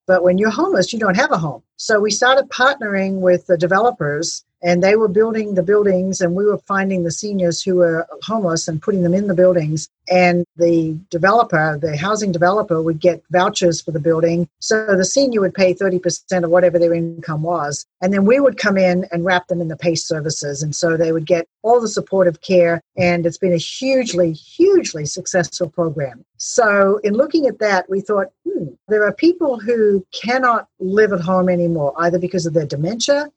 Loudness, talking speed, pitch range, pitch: -17 LUFS, 200 wpm, 170-210 Hz, 180 Hz